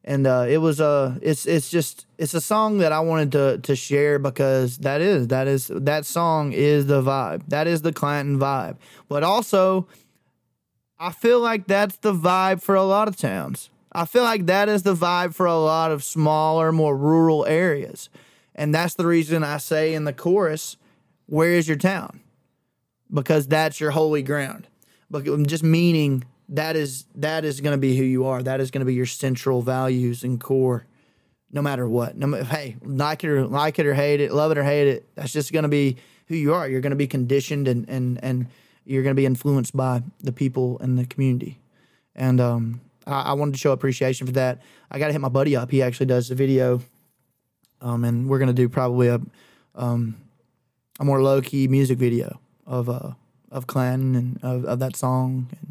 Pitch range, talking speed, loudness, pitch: 130-155 Hz, 200 wpm, -22 LUFS, 140 Hz